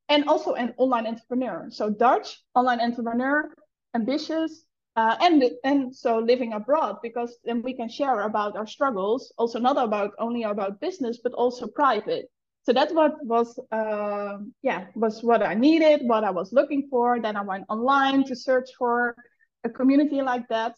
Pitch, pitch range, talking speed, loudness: 245 Hz, 225-275 Hz, 170 wpm, -24 LUFS